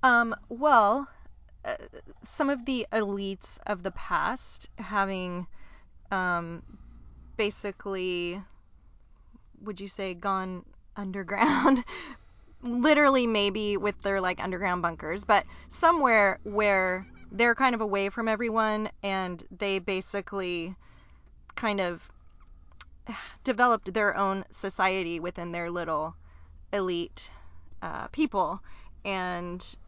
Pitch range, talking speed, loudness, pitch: 175-220 Hz, 100 wpm, -28 LUFS, 195 Hz